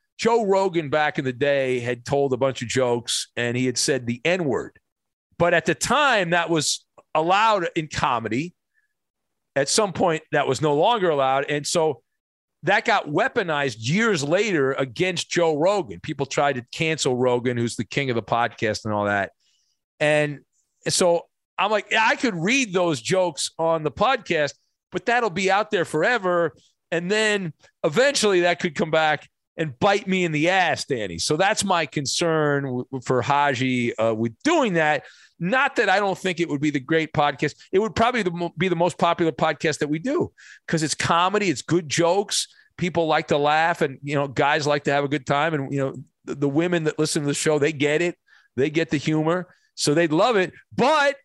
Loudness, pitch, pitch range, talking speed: -22 LUFS, 160 Hz, 140-180 Hz, 195 wpm